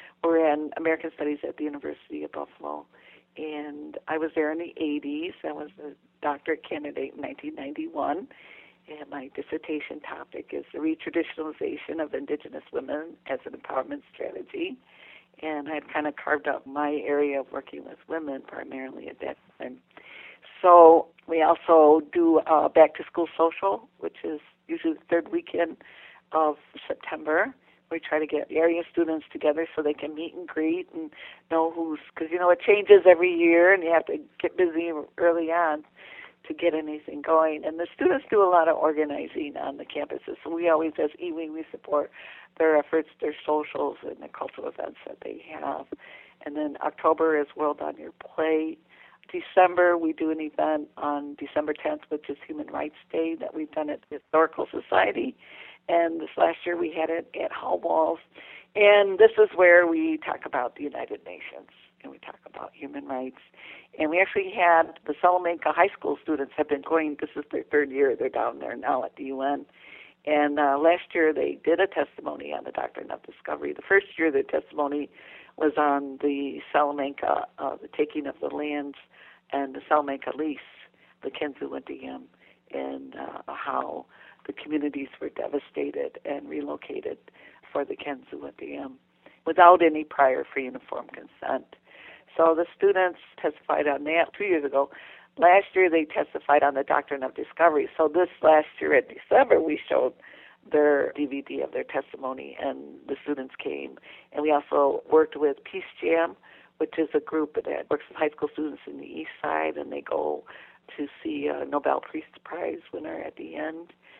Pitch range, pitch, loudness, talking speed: 150-175 Hz, 160 Hz, -25 LUFS, 180 wpm